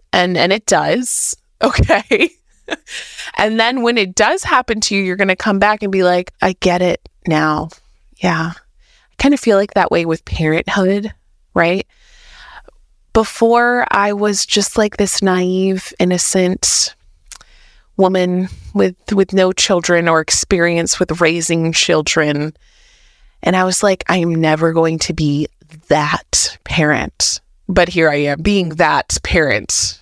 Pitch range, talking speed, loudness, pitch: 165-210 Hz, 145 wpm, -15 LUFS, 185 Hz